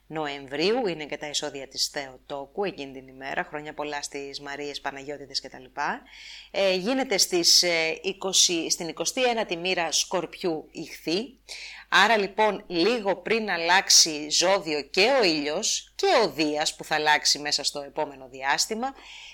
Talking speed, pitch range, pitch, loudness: 140 wpm, 145-195 Hz, 155 Hz, -24 LUFS